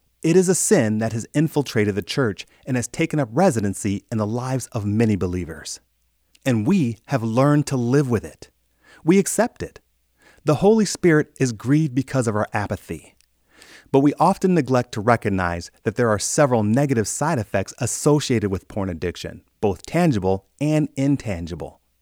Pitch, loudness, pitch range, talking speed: 115 Hz, -21 LUFS, 100-145 Hz, 165 wpm